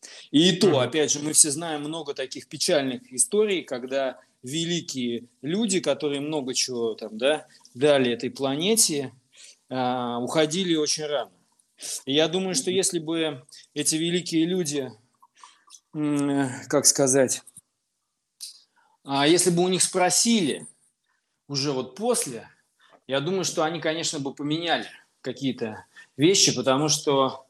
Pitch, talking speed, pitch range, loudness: 145 Hz, 120 wpm, 130-165 Hz, -24 LUFS